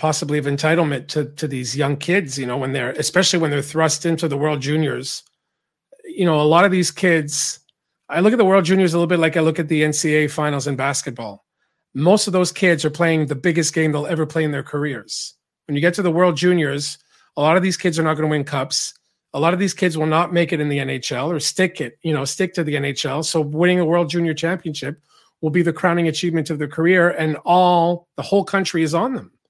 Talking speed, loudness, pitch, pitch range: 245 wpm, -19 LUFS, 160 Hz, 150-175 Hz